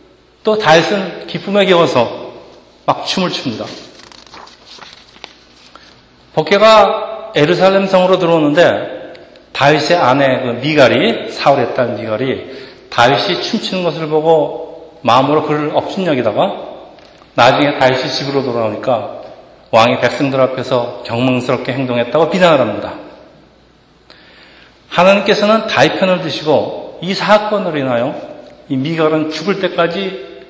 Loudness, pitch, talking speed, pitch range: -13 LUFS, 155 Hz, 270 characters per minute, 130-185 Hz